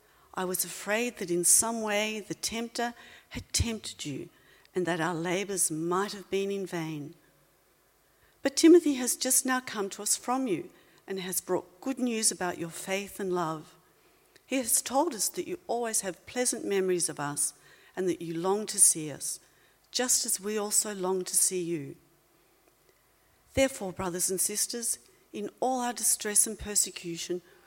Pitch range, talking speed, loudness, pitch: 180-240 Hz, 170 wpm, -28 LUFS, 200 Hz